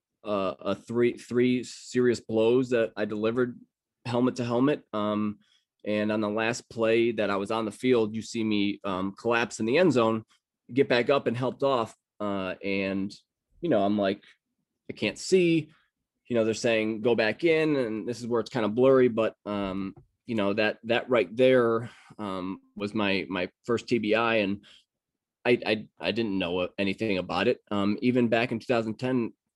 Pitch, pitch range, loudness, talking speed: 110 Hz, 105-120 Hz, -27 LUFS, 185 wpm